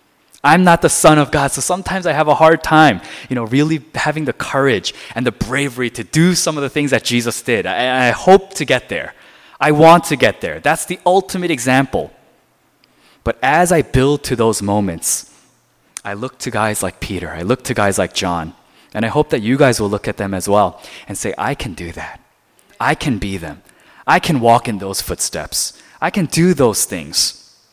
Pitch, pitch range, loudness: 140 Hz, 115-160 Hz, -15 LUFS